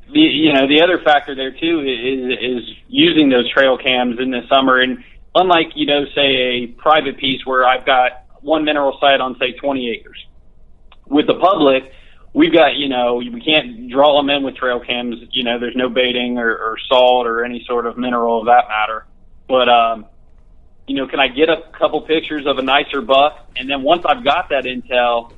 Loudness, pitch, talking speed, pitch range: -15 LUFS, 130 Hz, 205 wpm, 120-145 Hz